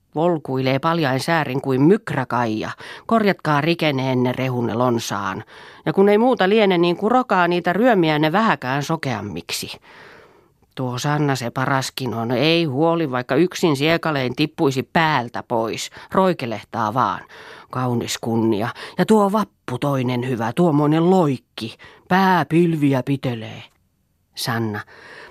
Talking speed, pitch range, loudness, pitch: 115 wpm, 125-170 Hz, -19 LUFS, 140 Hz